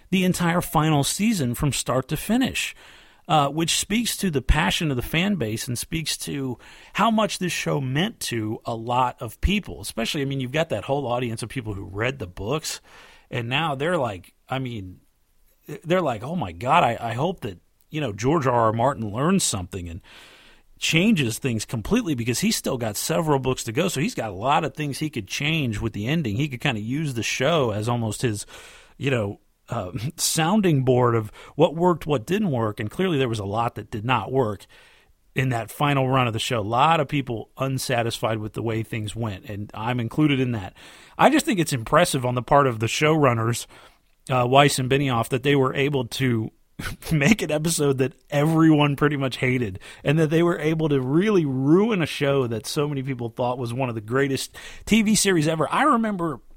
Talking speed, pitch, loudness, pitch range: 210 wpm, 135 Hz, -23 LUFS, 115-155 Hz